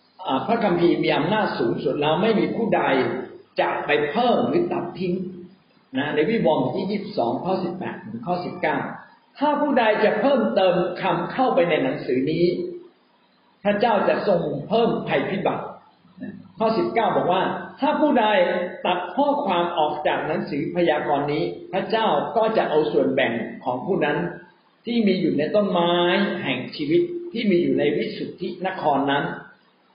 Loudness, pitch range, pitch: -22 LUFS, 175-225 Hz, 185 Hz